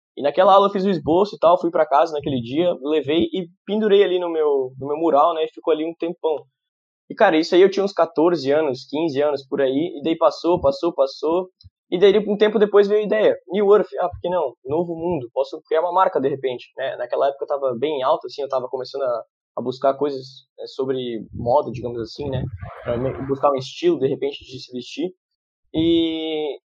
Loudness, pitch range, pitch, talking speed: -20 LUFS, 135-195 Hz, 160 Hz, 225 wpm